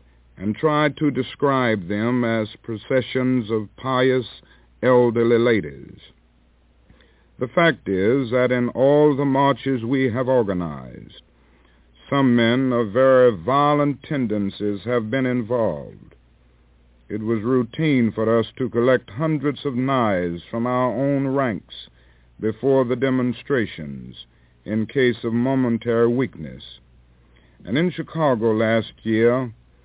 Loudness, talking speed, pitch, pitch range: -20 LUFS, 115 wpm, 120 Hz, 95-130 Hz